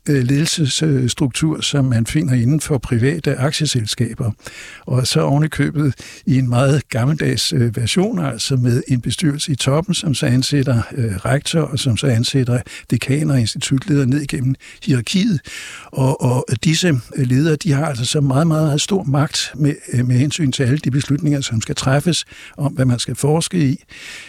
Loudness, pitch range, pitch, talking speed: -17 LUFS, 125-150 Hz, 140 Hz, 160 wpm